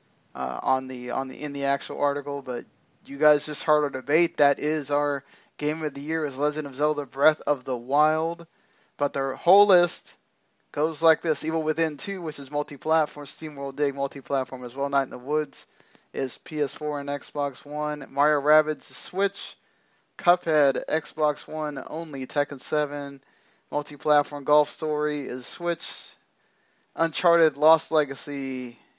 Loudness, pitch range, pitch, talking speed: -25 LUFS, 140-155 Hz, 150 Hz, 155 wpm